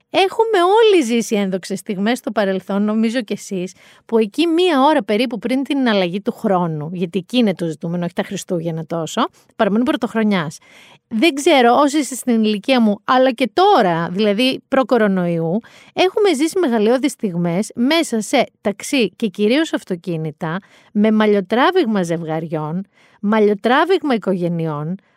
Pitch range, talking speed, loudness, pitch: 190-265 Hz, 140 wpm, -17 LUFS, 220 Hz